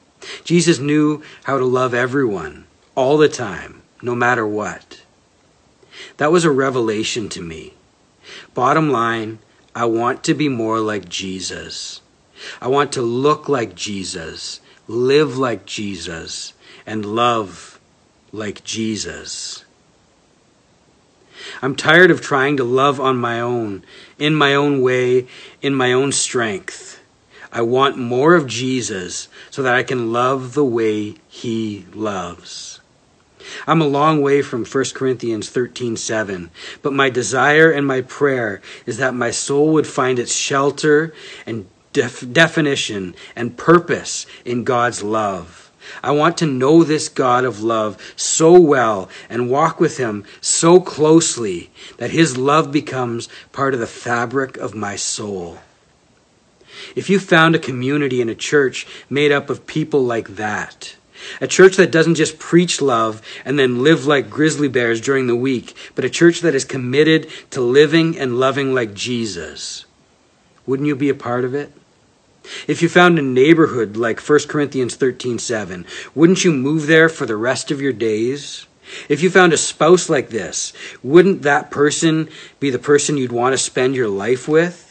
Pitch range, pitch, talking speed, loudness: 120-150 Hz, 130 Hz, 155 wpm, -17 LUFS